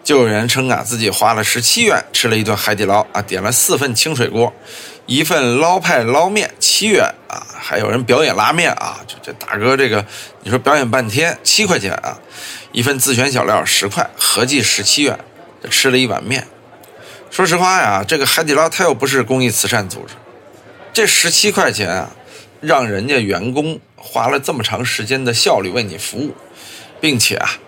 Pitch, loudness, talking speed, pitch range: 130 Hz, -14 LUFS, 275 characters per minute, 120-140 Hz